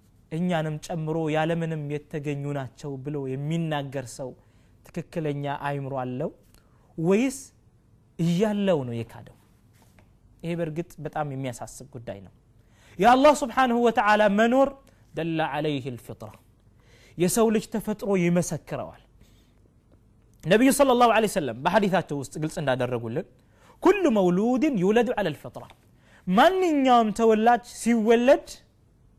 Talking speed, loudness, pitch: 100 wpm, -24 LUFS, 155 Hz